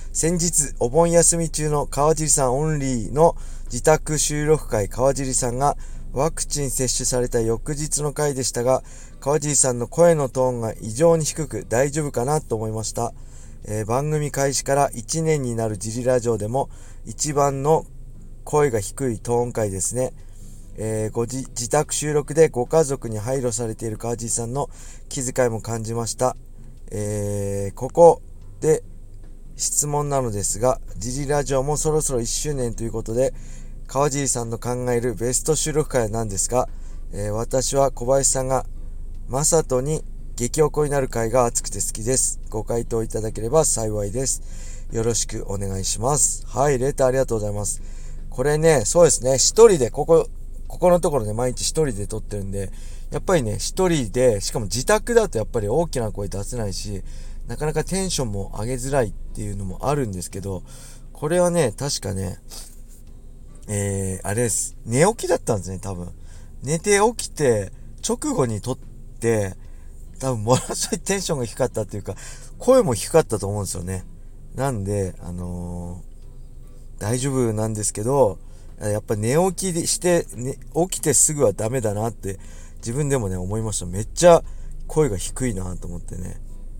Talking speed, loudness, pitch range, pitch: 325 characters per minute, -22 LUFS, 105-145 Hz, 120 Hz